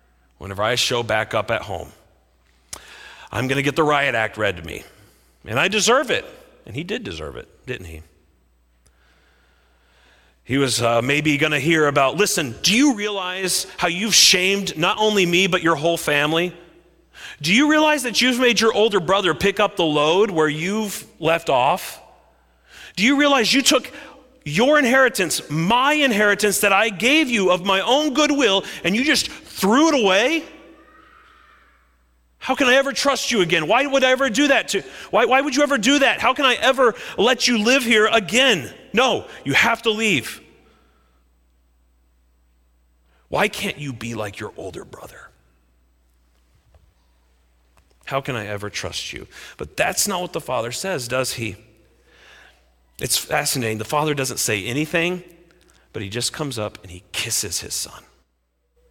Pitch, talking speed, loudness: 165 Hz, 165 wpm, -18 LUFS